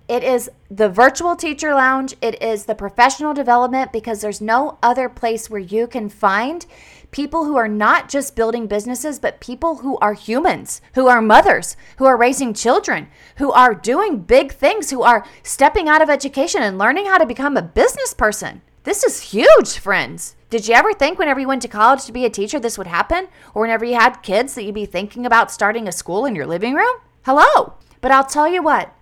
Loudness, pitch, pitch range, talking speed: -16 LUFS, 250 Hz, 225-290 Hz, 210 wpm